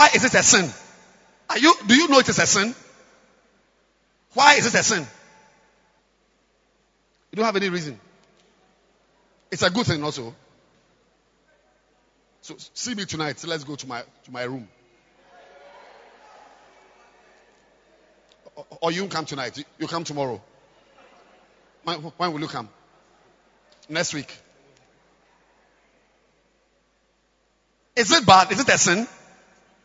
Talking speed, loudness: 125 wpm, -20 LUFS